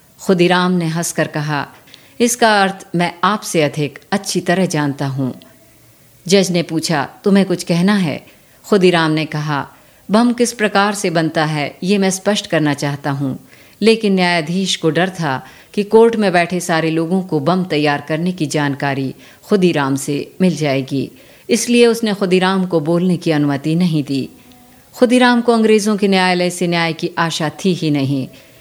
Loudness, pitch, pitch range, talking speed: -16 LUFS, 175 Hz, 150-195 Hz, 160 wpm